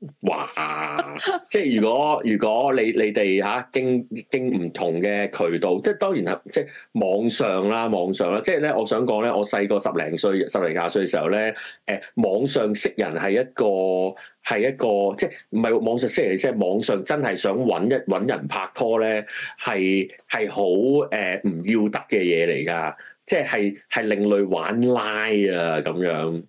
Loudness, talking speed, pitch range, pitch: -22 LUFS, 240 characters per minute, 95-115 Hz, 105 Hz